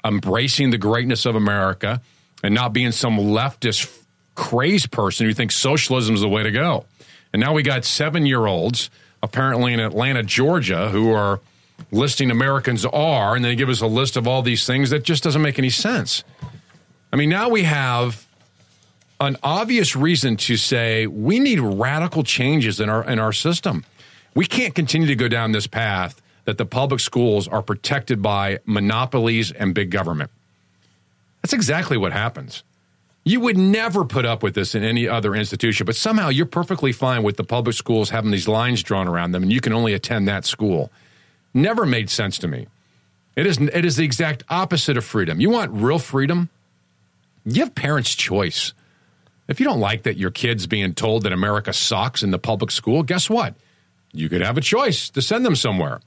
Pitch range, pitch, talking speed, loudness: 105-140 Hz, 120 Hz, 190 wpm, -19 LUFS